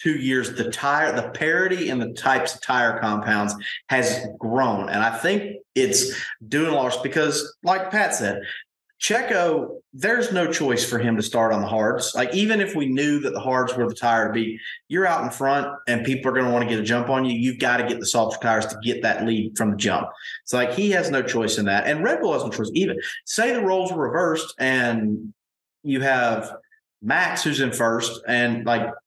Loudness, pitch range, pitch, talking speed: -22 LUFS, 115-150 Hz, 125 Hz, 225 wpm